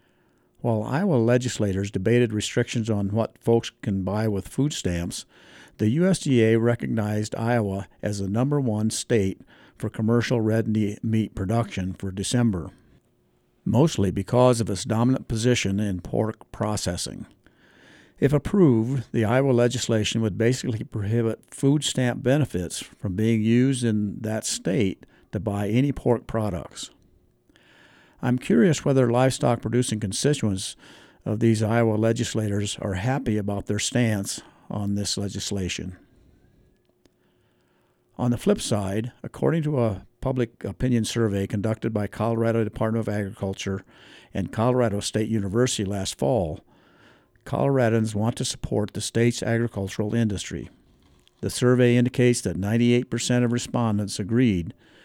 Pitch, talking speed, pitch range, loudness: 115 Hz, 125 wpm, 105-120 Hz, -24 LUFS